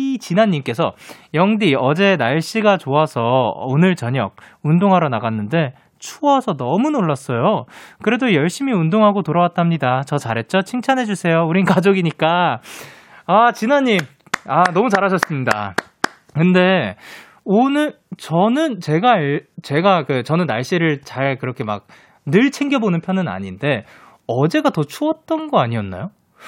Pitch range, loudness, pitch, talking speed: 140-210 Hz, -17 LUFS, 175 Hz, 285 characters per minute